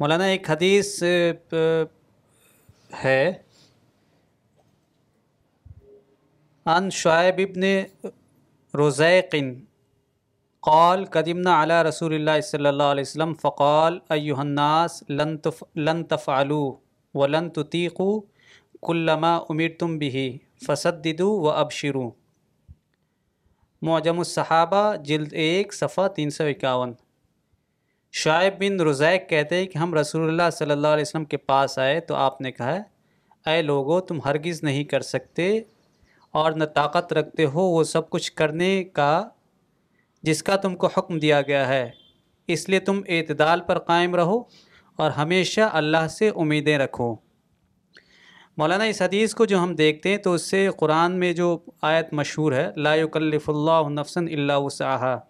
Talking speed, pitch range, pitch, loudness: 135 wpm, 145-175 Hz, 160 Hz, -22 LUFS